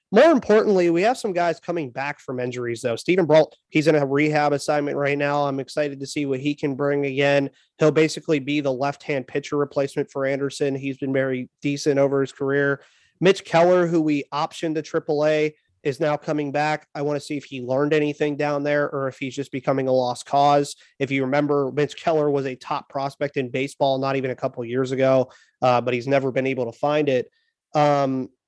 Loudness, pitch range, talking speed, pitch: -22 LUFS, 135-150 Hz, 215 wpm, 145 Hz